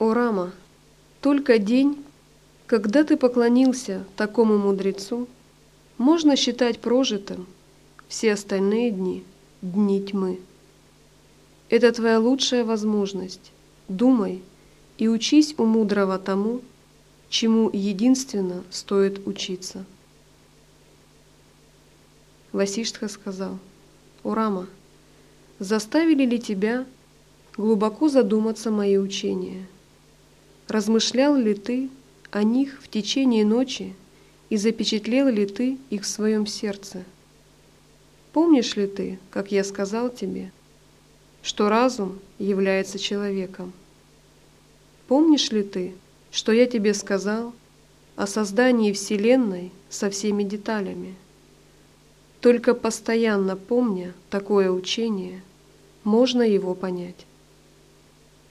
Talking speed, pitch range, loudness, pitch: 90 wpm, 195-235 Hz, -23 LUFS, 210 Hz